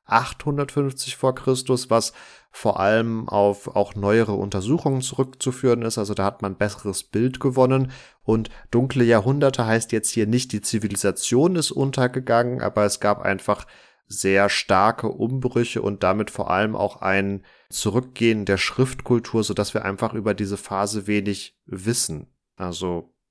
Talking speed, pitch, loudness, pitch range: 140 wpm, 110 Hz, -22 LUFS, 100-125 Hz